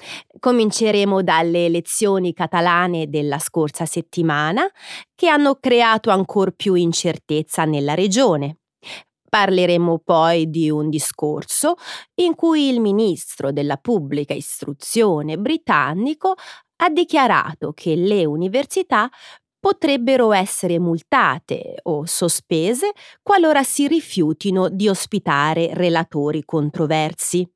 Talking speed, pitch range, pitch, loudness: 100 wpm, 160-245 Hz, 180 Hz, -18 LUFS